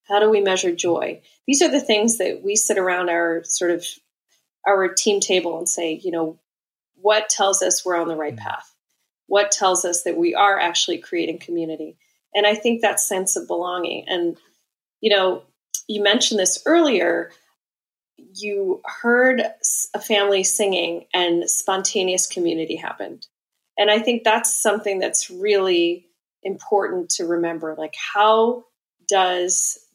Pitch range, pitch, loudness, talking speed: 175-210 Hz, 195 Hz, -20 LUFS, 150 wpm